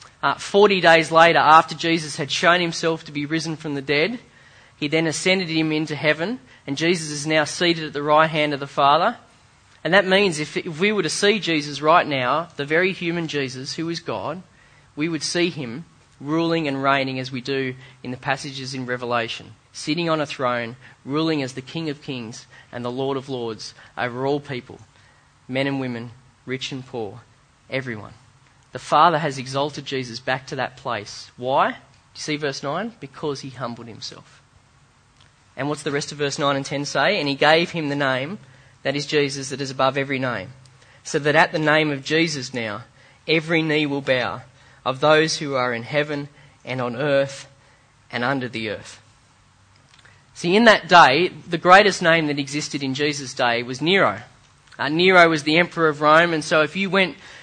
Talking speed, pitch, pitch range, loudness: 195 wpm, 140 Hz, 130-160 Hz, -20 LUFS